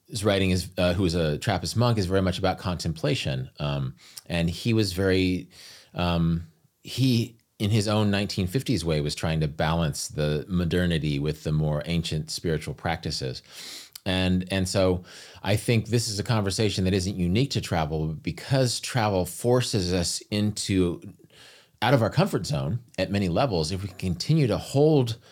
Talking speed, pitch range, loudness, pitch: 170 wpm, 85-115 Hz, -26 LUFS, 95 Hz